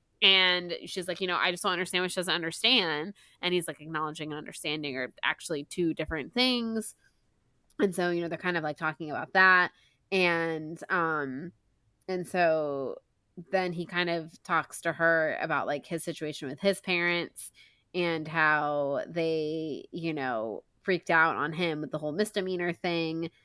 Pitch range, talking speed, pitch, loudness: 155-180 Hz, 170 wpm, 165 Hz, -29 LUFS